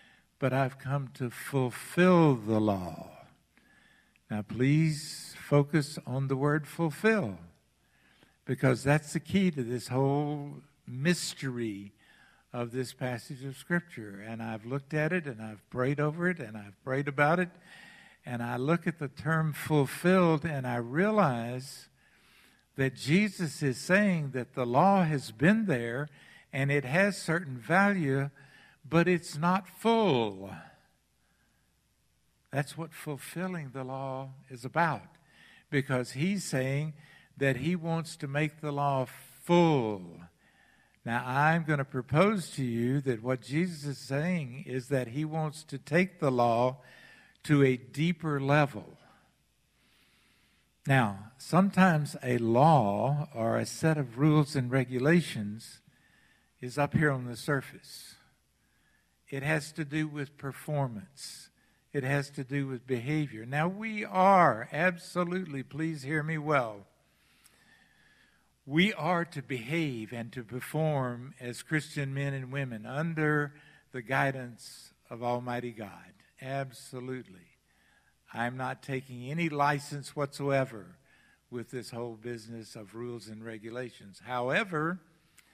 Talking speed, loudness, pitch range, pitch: 130 wpm, -30 LUFS, 125-155 Hz, 140 Hz